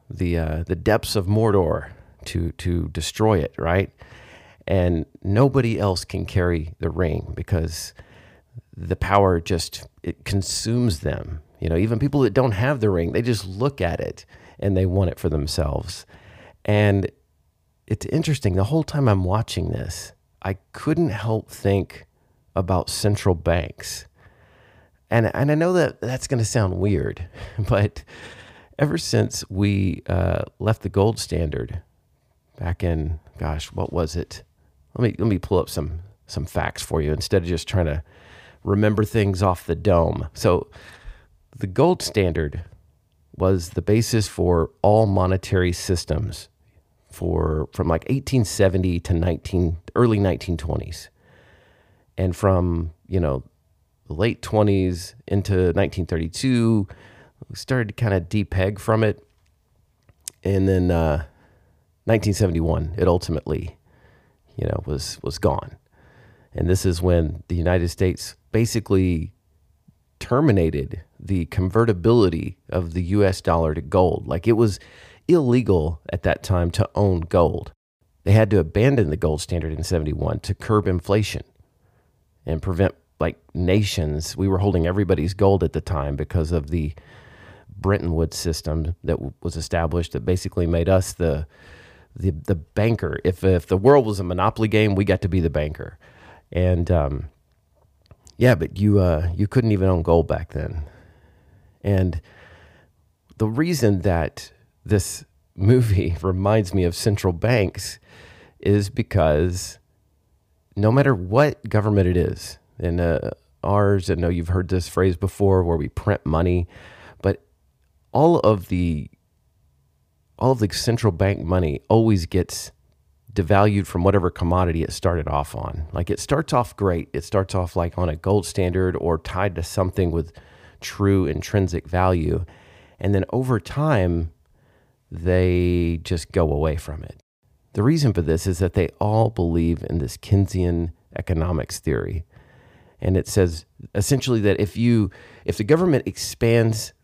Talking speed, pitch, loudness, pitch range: 145 wpm, 95 Hz, -22 LUFS, 85-105 Hz